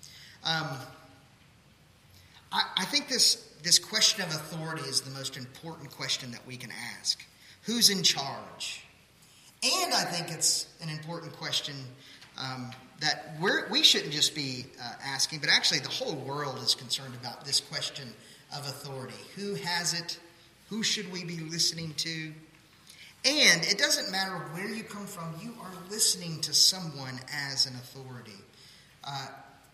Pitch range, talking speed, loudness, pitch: 135-175 Hz, 150 wpm, -27 LUFS, 155 Hz